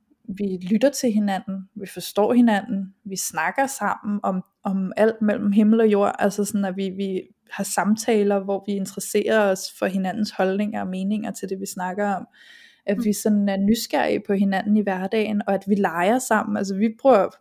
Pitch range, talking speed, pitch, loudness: 195-220 Hz, 190 wpm, 205 Hz, -22 LUFS